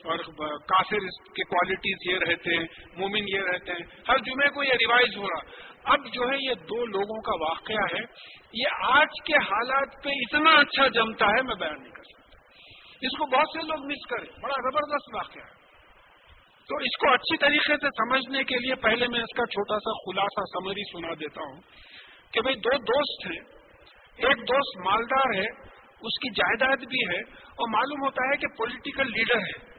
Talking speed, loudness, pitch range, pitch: 190 wpm, -25 LUFS, 195-275 Hz, 240 Hz